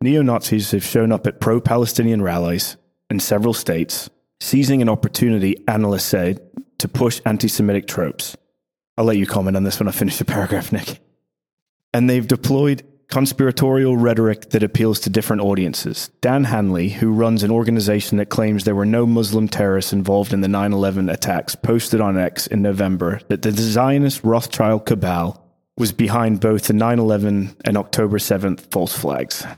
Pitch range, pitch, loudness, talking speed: 100-120 Hz, 110 Hz, -18 LUFS, 170 wpm